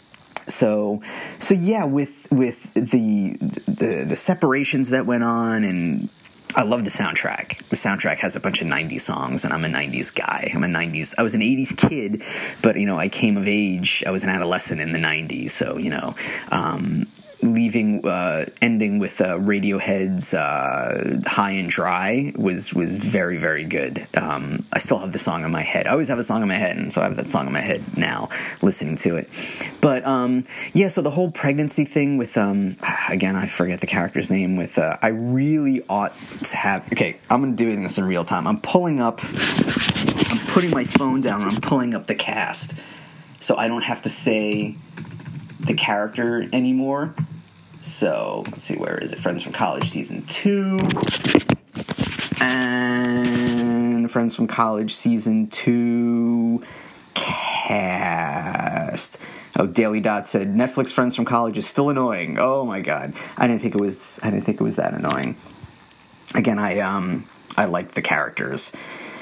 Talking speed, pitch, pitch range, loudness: 175 wpm, 120 Hz, 105-150 Hz, -21 LUFS